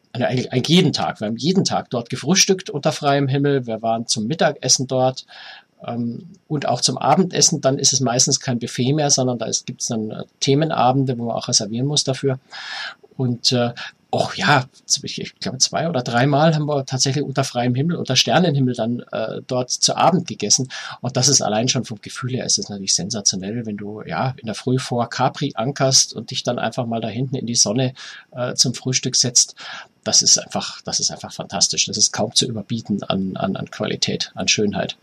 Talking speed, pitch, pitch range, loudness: 200 wpm, 130 Hz, 120-140 Hz, -19 LUFS